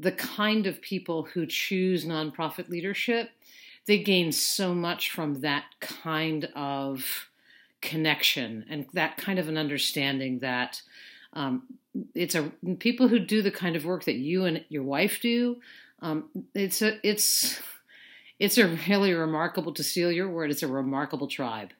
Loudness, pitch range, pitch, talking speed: -27 LUFS, 150-200 Hz, 175 Hz, 155 wpm